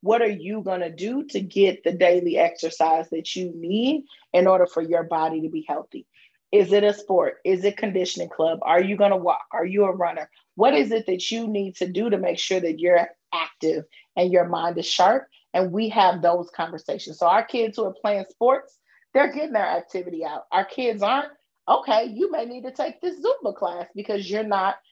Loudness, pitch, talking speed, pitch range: -23 LUFS, 190 Hz, 215 wpm, 175-220 Hz